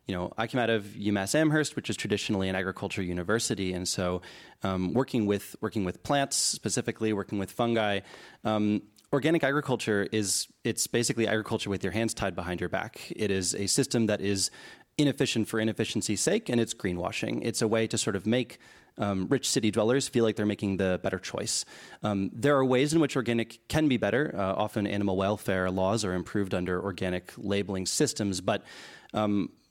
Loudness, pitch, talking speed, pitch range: -29 LUFS, 105 Hz, 190 wpm, 95-115 Hz